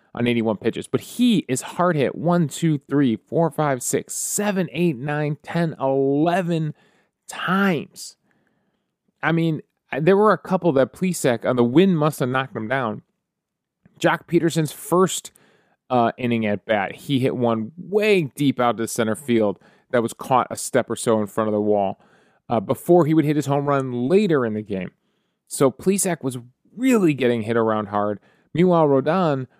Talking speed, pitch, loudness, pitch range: 175 wpm, 150 Hz, -21 LUFS, 120-175 Hz